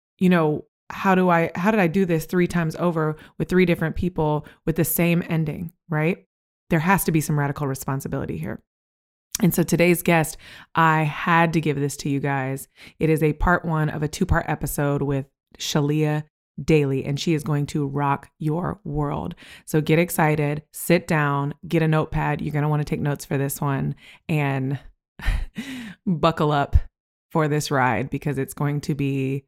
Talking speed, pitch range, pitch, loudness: 185 wpm, 140-170 Hz, 155 Hz, -23 LUFS